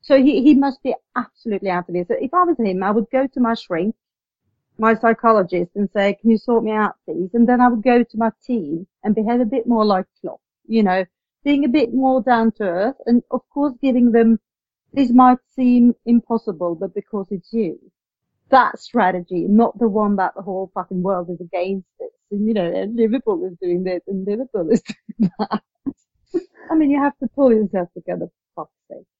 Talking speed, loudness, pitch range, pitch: 205 wpm, -19 LUFS, 195-250 Hz, 225 Hz